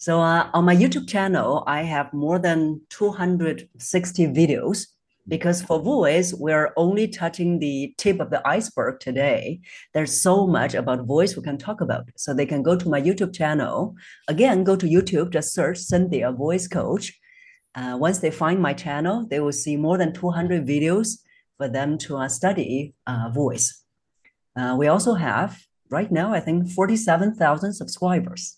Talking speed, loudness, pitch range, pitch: 170 wpm, -22 LUFS, 145-185 Hz, 165 Hz